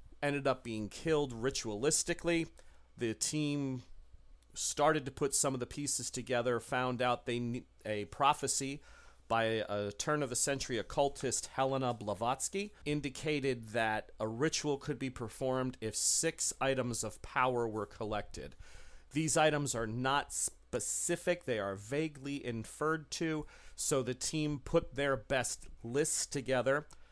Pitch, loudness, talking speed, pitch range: 135 Hz, -35 LUFS, 135 wpm, 115-145 Hz